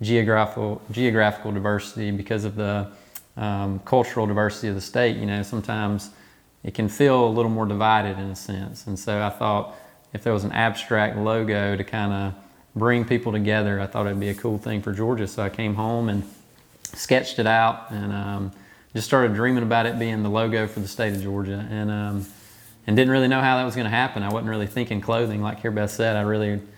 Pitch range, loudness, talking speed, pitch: 100-115 Hz, -23 LUFS, 215 wpm, 105 Hz